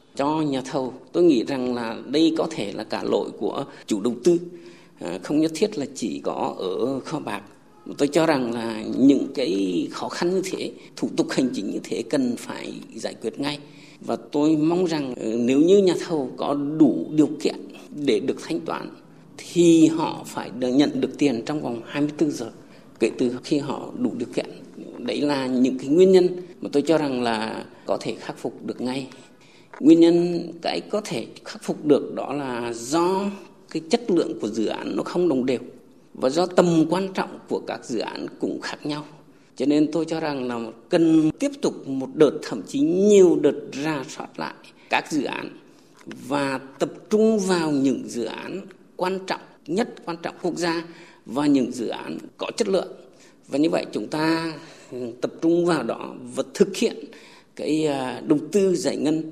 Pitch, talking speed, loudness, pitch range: 160 Hz, 190 wpm, -23 LUFS, 135-185 Hz